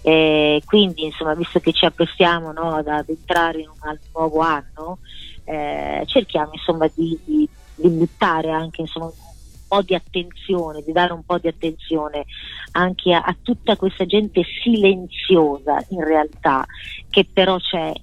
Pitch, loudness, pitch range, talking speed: 165 Hz, -19 LUFS, 155-180 Hz, 150 wpm